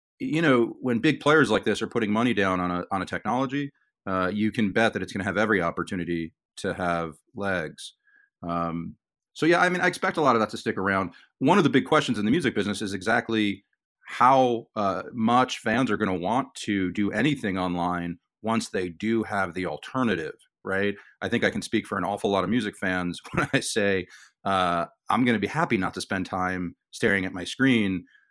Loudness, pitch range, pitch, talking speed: -25 LUFS, 90-115 Hz, 100 Hz, 220 wpm